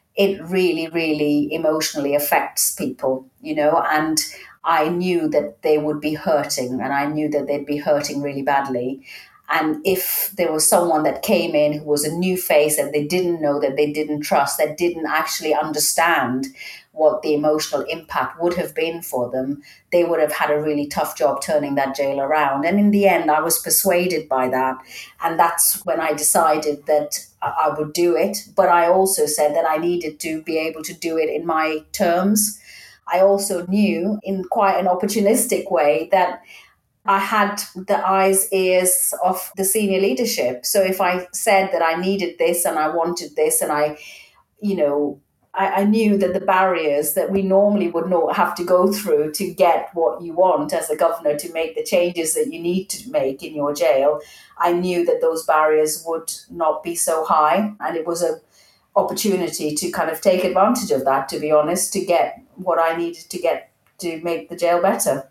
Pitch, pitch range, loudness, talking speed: 165 Hz, 150-185 Hz, -19 LUFS, 195 wpm